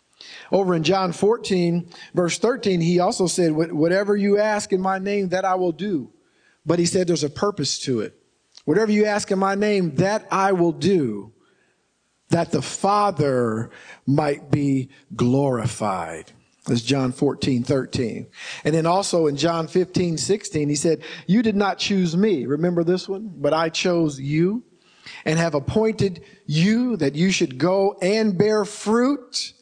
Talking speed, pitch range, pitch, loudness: 160 wpm, 150-195 Hz, 175 Hz, -21 LUFS